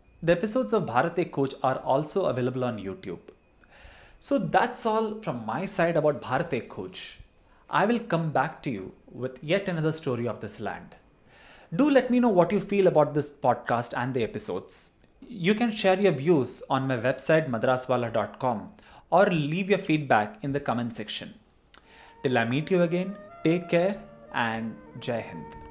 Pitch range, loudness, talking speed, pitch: 130-195 Hz, -26 LUFS, 170 wpm, 160 Hz